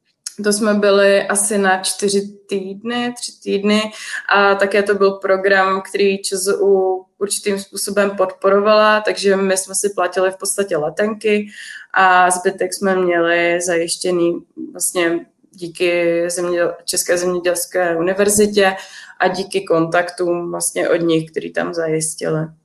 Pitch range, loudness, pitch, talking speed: 175-200 Hz, -16 LUFS, 190 Hz, 120 wpm